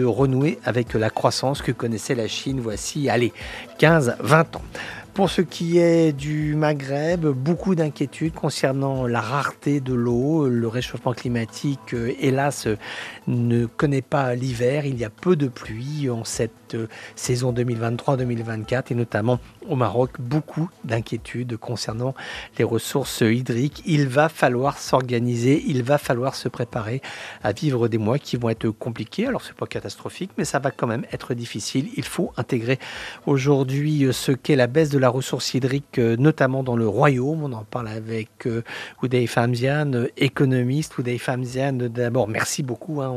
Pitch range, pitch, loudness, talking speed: 120-145 Hz, 130 Hz, -23 LUFS, 160 wpm